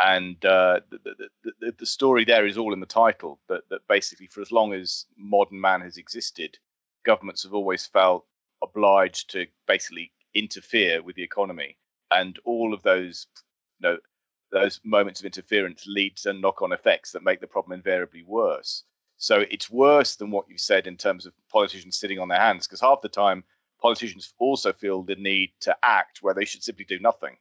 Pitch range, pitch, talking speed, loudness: 95-120 Hz, 100 Hz, 190 wpm, -24 LUFS